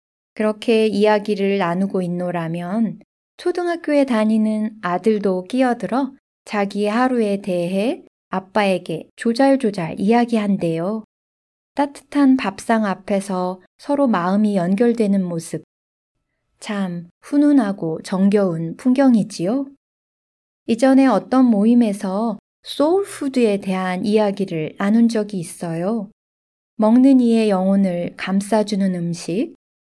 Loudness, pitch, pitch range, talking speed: -19 LUFS, 210 Hz, 185-235 Hz, 245 characters per minute